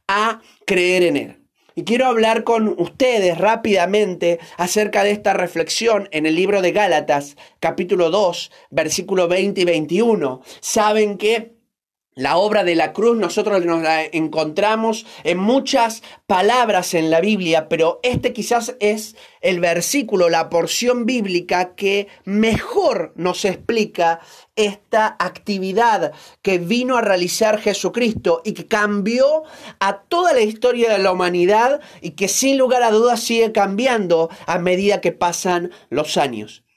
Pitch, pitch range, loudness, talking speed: 200 Hz, 175-225 Hz, -18 LUFS, 140 wpm